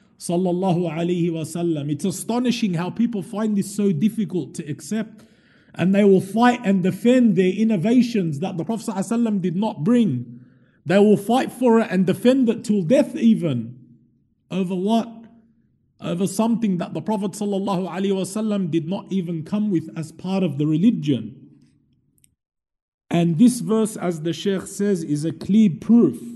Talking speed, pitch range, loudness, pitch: 150 wpm, 170-220 Hz, -21 LUFS, 195 Hz